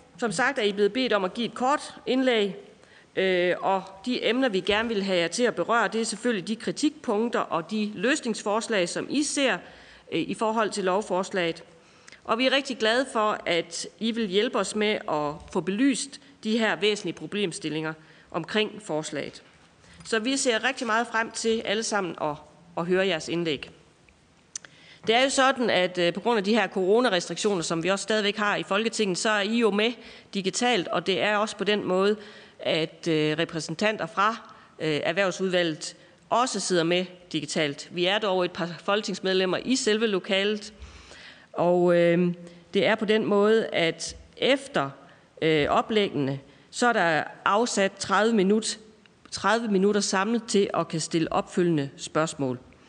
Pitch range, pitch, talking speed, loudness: 175-225 Hz, 200 Hz, 165 wpm, -25 LUFS